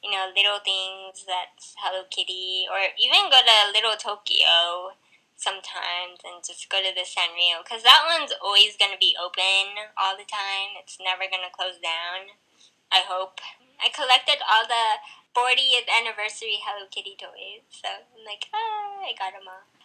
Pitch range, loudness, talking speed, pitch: 185-225 Hz, -21 LUFS, 165 wpm, 195 Hz